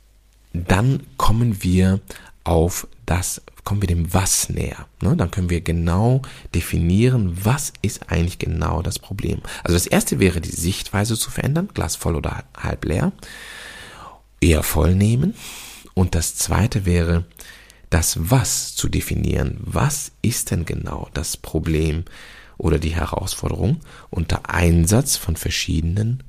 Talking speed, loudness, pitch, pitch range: 130 wpm, -21 LUFS, 95 Hz, 85-110 Hz